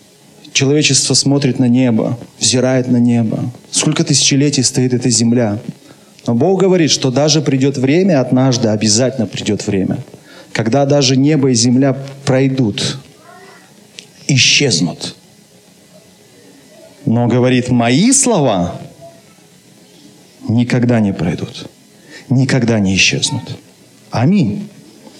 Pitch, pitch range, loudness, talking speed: 130 Hz, 120-145 Hz, -13 LUFS, 100 wpm